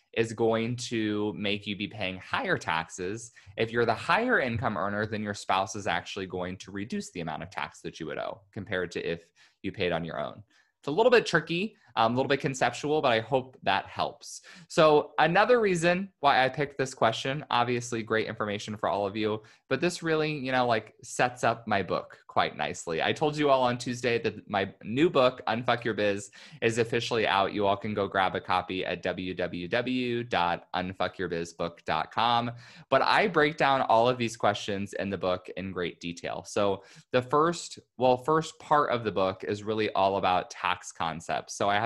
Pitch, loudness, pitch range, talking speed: 115 Hz, -28 LUFS, 100-130 Hz, 195 wpm